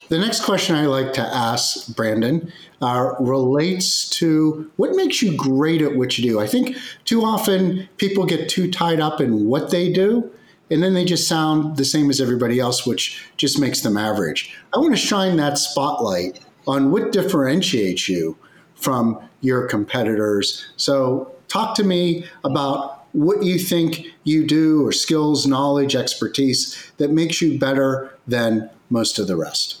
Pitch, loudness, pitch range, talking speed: 150 Hz, -19 LUFS, 130-175 Hz, 165 wpm